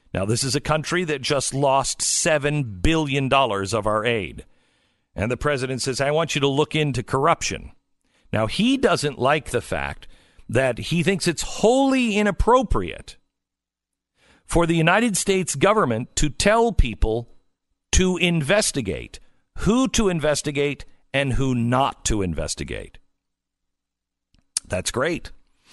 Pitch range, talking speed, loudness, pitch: 110-175 Hz, 130 wpm, -21 LUFS, 140 Hz